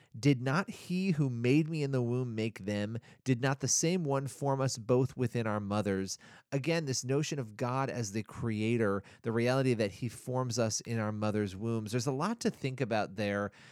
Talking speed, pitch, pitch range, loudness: 205 wpm, 125 Hz, 110-135 Hz, -33 LUFS